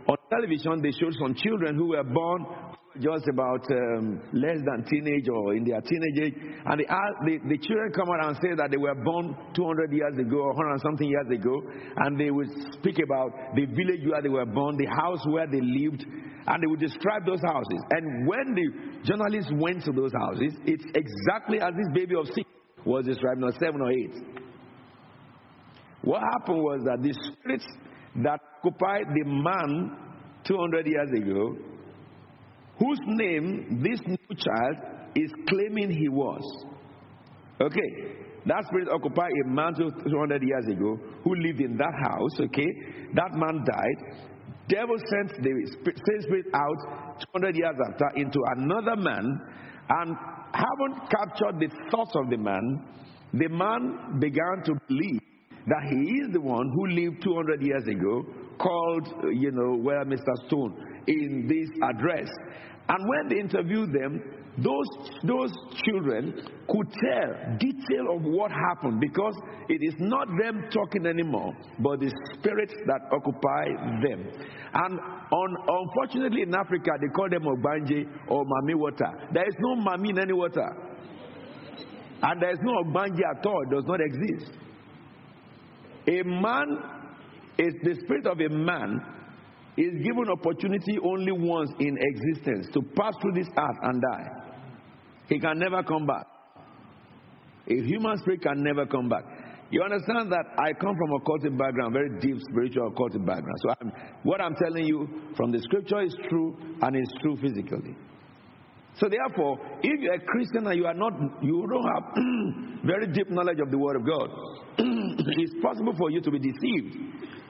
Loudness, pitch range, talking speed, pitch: -28 LUFS, 140-195 Hz, 165 wpm, 160 Hz